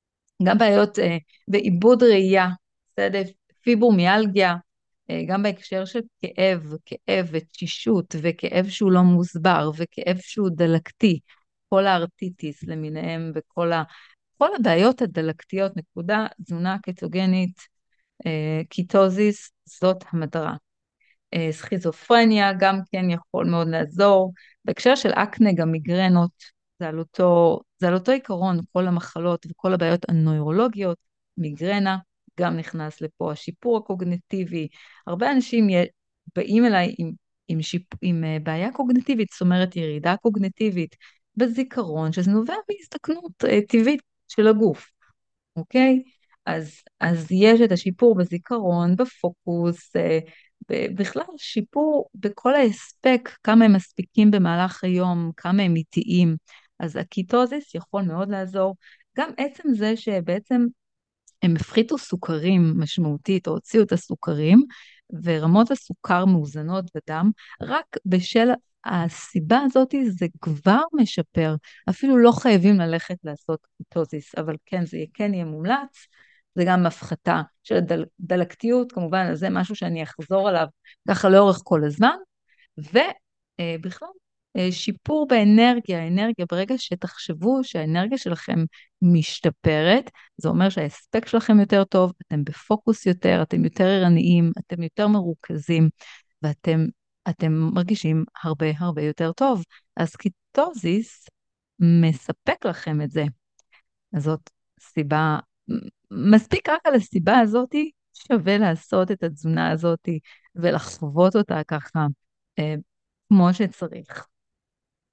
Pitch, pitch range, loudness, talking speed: 185 Hz, 165-215 Hz, -22 LUFS, 115 wpm